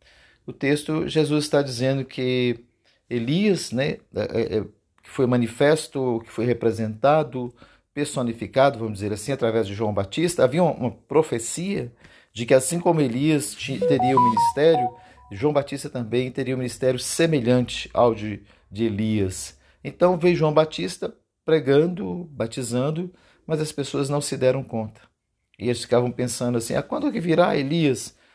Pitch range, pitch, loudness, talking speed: 115-150 Hz, 130 Hz, -23 LUFS, 155 wpm